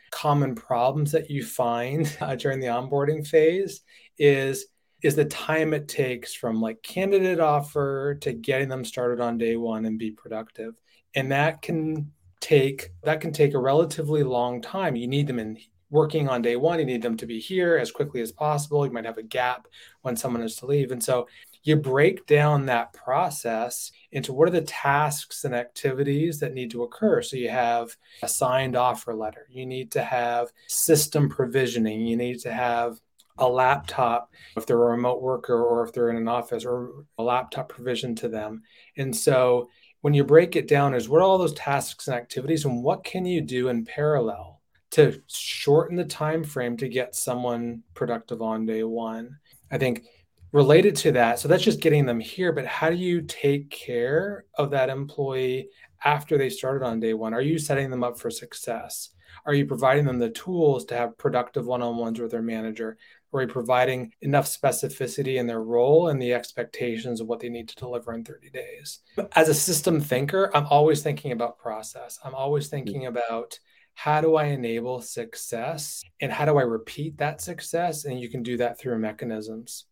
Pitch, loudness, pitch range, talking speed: 130 Hz, -25 LUFS, 120-150 Hz, 195 wpm